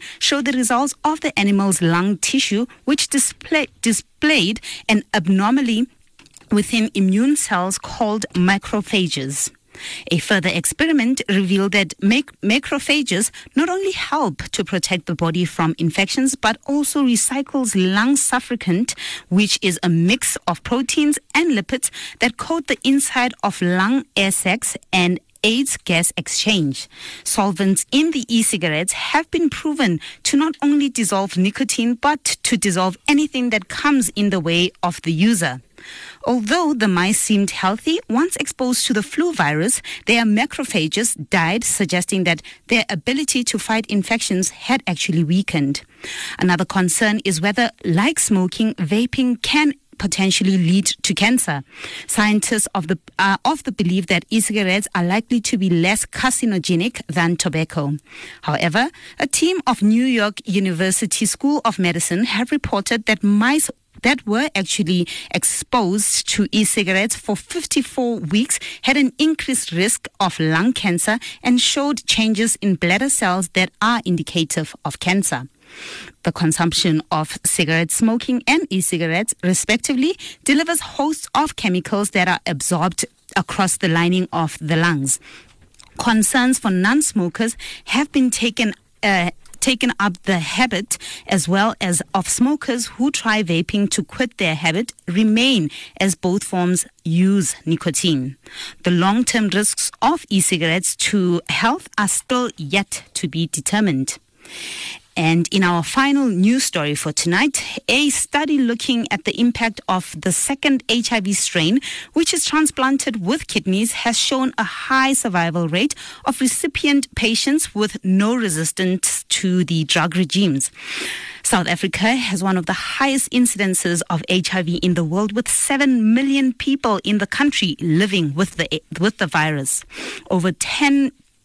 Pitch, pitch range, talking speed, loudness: 210 Hz, 180-255 Hz, 145 wpm, -18 LUFS